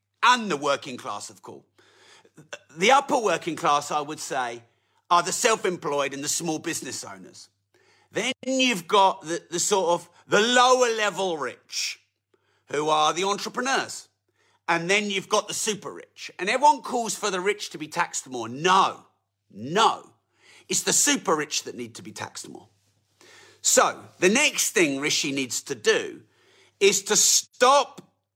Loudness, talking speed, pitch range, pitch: -23 LUFS, 165 wpm, 150-245 Hz, 190 Hz